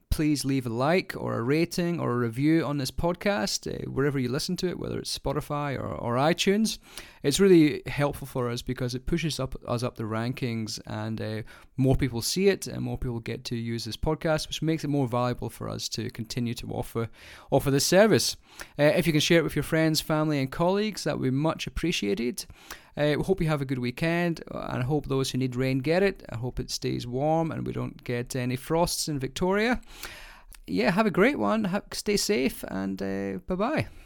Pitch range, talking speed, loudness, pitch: 120-165 Hz, 220 wpm, -27 LUFS, 140 Hz